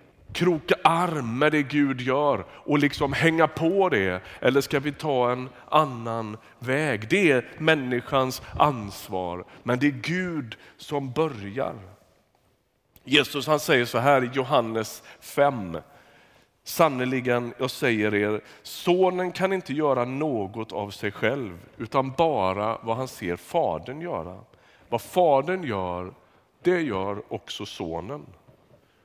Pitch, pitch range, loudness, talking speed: 130 Hz, 110-150 Hz, -25 LUFS, 130 wpm